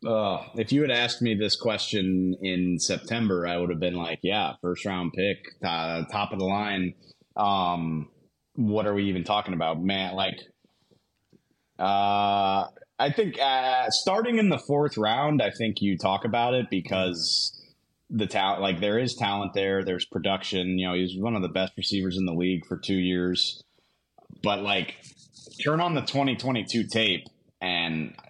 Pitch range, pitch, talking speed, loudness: 90-120 Hz, 100 Hz, 170 wpm, -26 LUFS